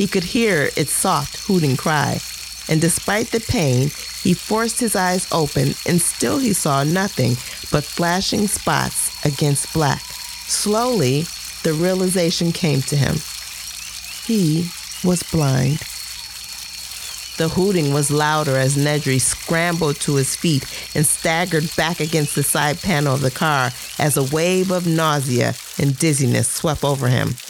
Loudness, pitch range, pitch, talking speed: -19 LUFS, 140-180 Hz, 155 Hz, 140 wpm